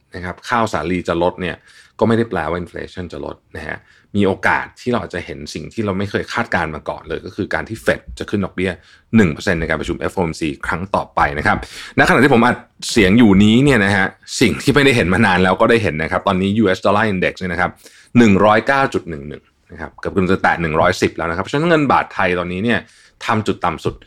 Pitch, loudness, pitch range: 95 Hz, -16 LUFS, 90-110 Hz